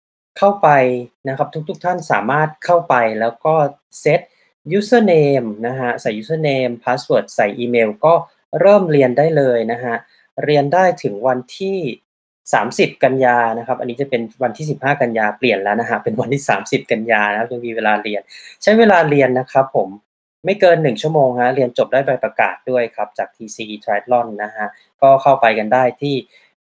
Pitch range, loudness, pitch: 115-150 Hz, -16 LUFS, 130 Hz